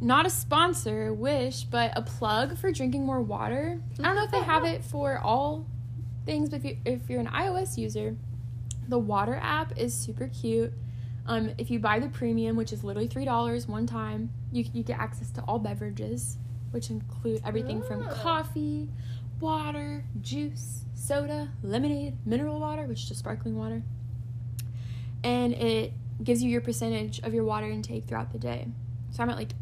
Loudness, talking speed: -30 LUFS, 175 wpm